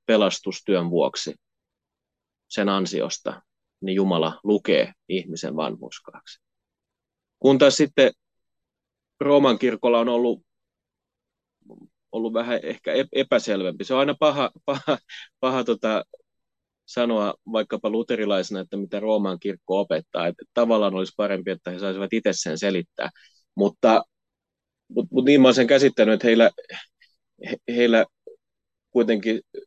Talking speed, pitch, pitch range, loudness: 115 wpm, 115 Hz, 95-130 Hz, -22 LUFS